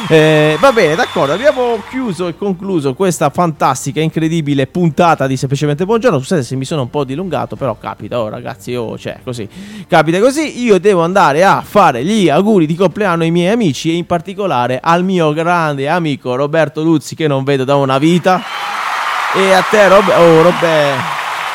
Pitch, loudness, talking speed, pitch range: 165 Hz, -12 LUFS, 180 wpm, 145-190 Hz